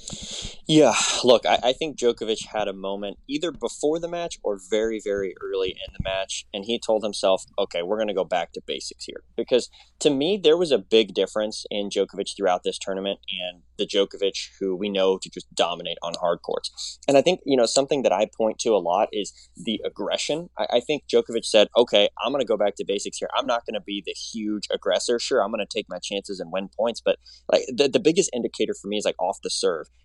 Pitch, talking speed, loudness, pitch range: 110 Hz, 235 wpm, -24 LUFS, 100-155 Hz